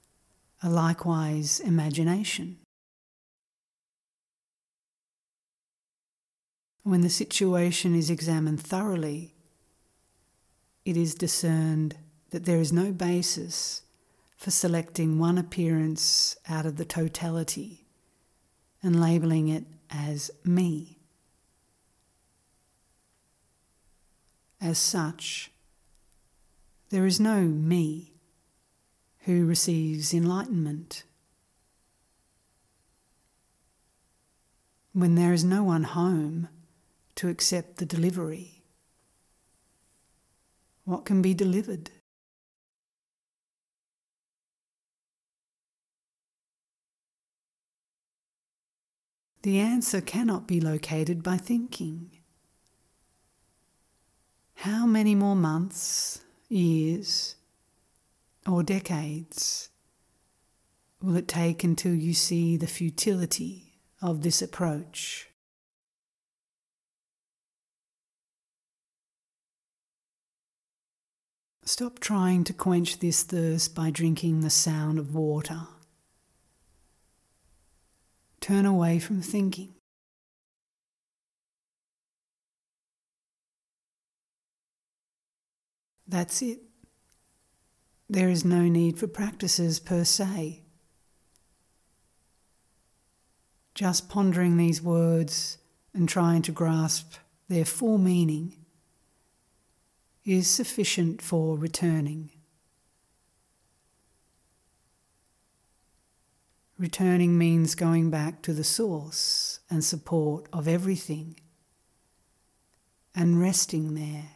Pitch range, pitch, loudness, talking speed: 155-180 Hz, 165 Hz, -26 LUFS, 70 wpm